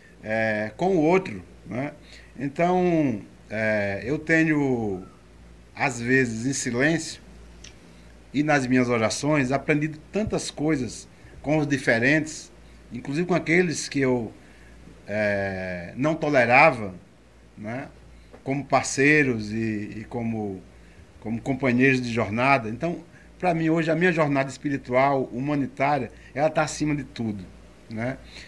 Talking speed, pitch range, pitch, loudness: 120 wpm, 100-150 Hz, 130 Hz, -24 LUFS